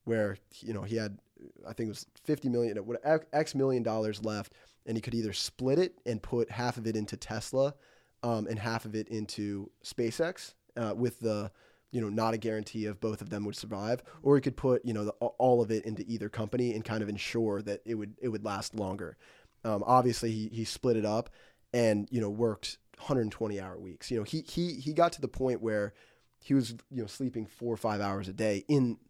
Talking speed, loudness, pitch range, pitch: 225 wpm, -33 LUFS, 105-125 Hz, 115 Hz